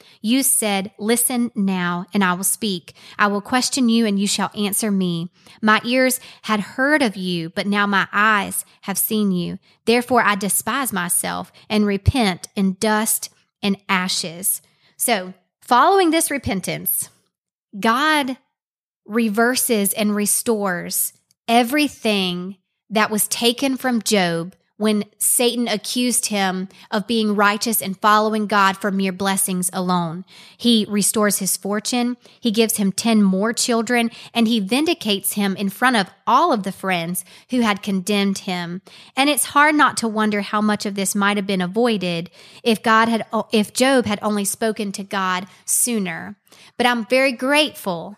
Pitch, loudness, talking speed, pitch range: 210 Hz, -19 LUFS, 150 wpm, 190-235 Hz